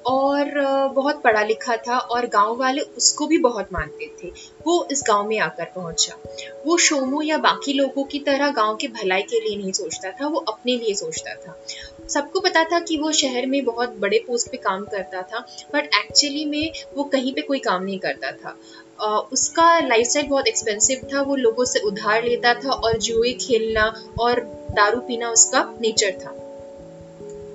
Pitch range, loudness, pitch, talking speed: 210-285 Hz, -20 LUFS, 245 Hz, 185 wpm